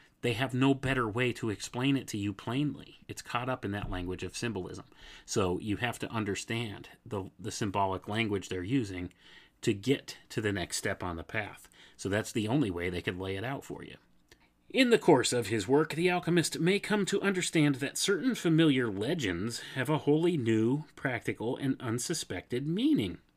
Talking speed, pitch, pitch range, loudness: 195 wpm, 120 Hz, 105-145 Hz, -31 LUFS